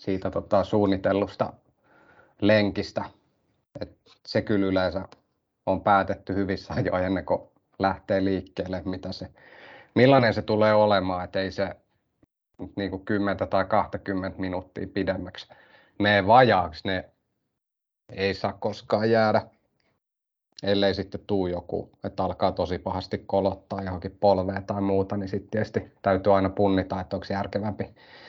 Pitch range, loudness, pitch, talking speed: 95-100 Hz, -25 LUFS, 100 Hz, 130 wpm